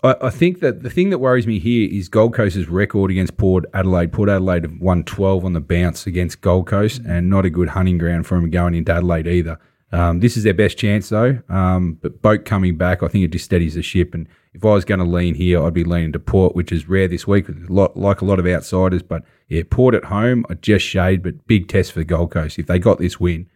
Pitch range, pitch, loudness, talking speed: 85-105 Hz, 90 Hz, -17 LUFS, 255 wpm